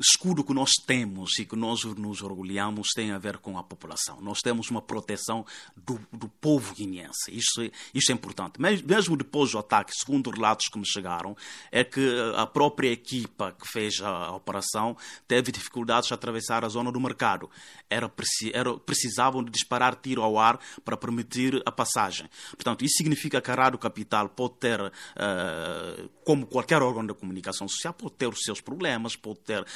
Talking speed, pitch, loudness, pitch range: 175 wpm, 115 Hz, -27 LUFS, 105-130 Hz